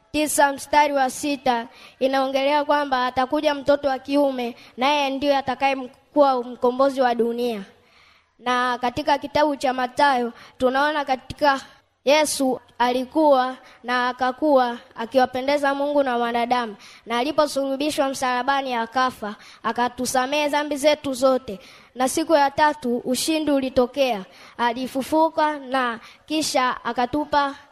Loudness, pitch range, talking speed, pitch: -22 LUFS, 245-285 Hz, 105 wpm, 265 Hz